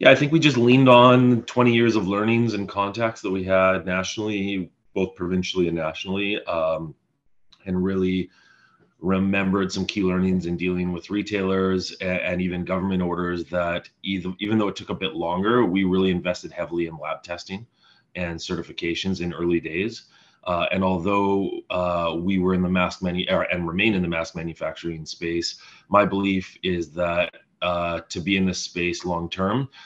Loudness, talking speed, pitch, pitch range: -23 LUFS, 175 wpm, 95 Hz, 90-100 Hz